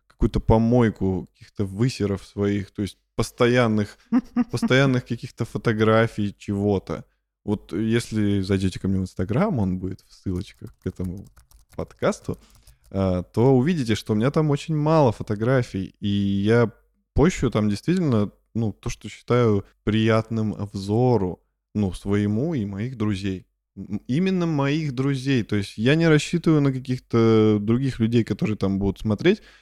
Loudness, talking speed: -23 LUFS, 135 wpm